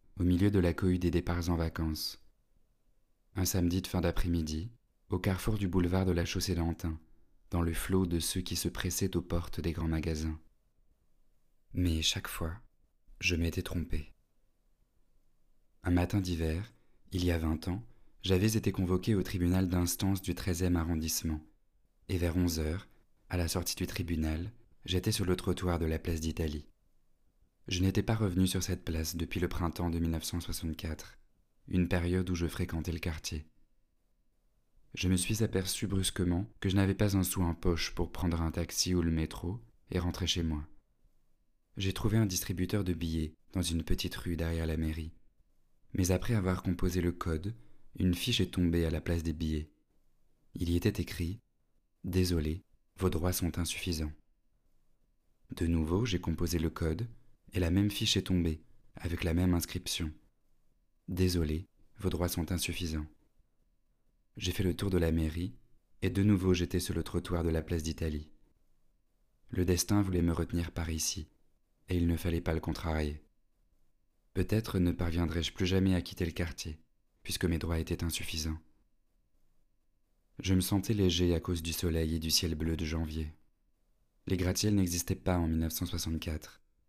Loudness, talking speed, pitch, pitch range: -33 LUFS, 165 wpm, 85 Hz, 80-95 Hz